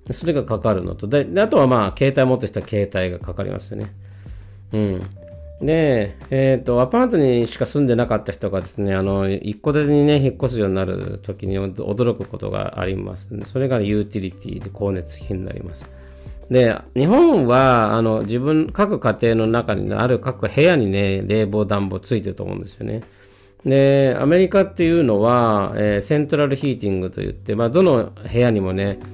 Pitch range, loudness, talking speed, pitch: 100-130 Hz, -19 LUFS, 375 characters per minute, 110 Hz